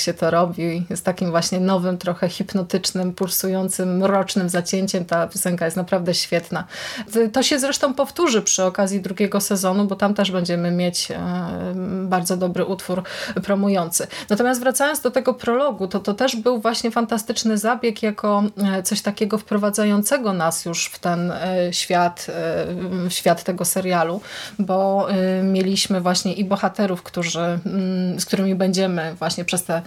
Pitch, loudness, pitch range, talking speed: 190 Hz, -21 LUFS, 180-205 Hz, 140 wpm